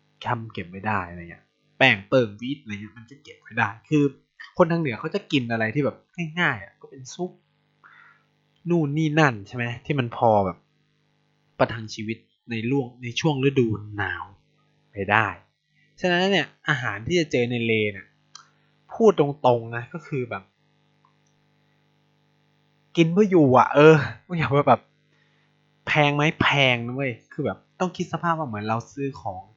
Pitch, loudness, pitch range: 135 Hz, -23 LUFS, 115-155 Hz